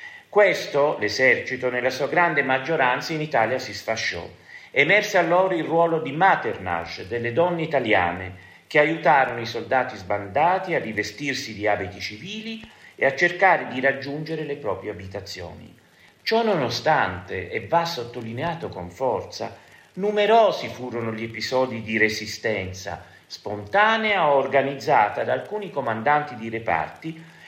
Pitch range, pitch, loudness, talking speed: 110-170 Hz, 135 Hz, -22 LUFS, 125 wpm